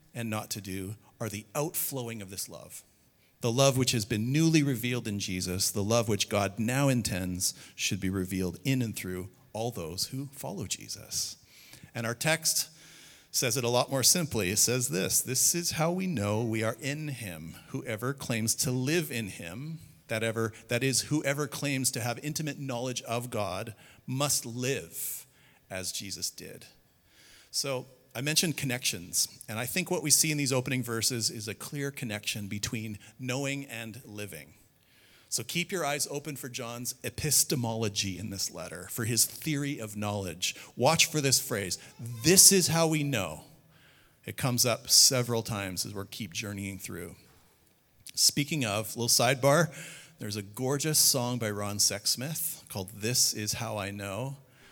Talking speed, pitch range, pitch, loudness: 170 wpm, 105-140 Hz, 120 Hz, -28 LUFS